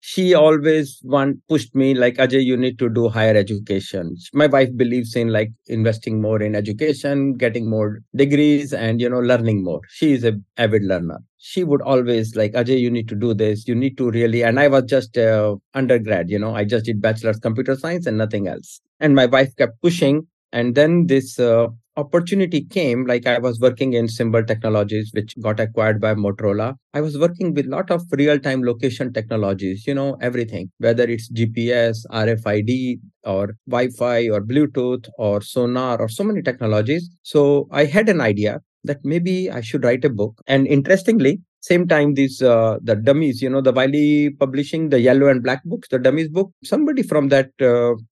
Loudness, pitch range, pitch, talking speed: -18 LUFS, 110-145 Hz, 125 Hz, 195 wpm